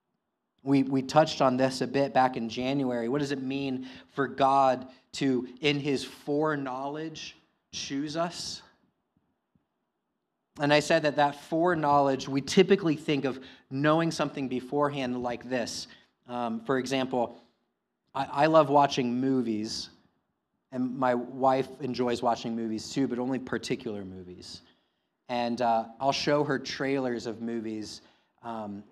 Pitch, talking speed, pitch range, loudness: 130 Hz, 135 wpm, 120-145 Hz, -28 LUFS